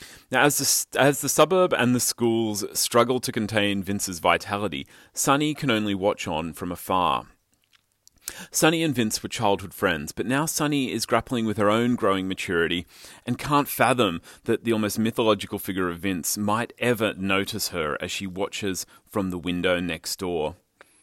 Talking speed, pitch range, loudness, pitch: 170 wpm, 95-125 Hz, -24 LUFS, 105 Hz